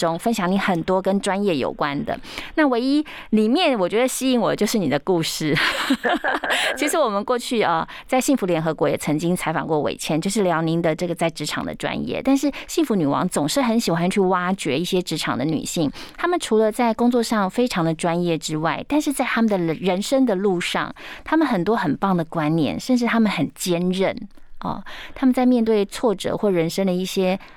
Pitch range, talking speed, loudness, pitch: 170-250 Hz, 310 characters per minute, -21 LUFS, 195 Hz